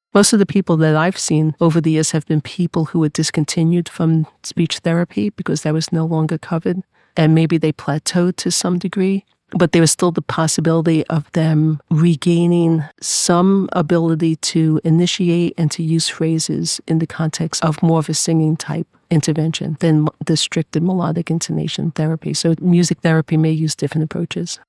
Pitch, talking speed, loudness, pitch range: 165 Hz, 175 wpm, -17 LUFS, 160-175 Hz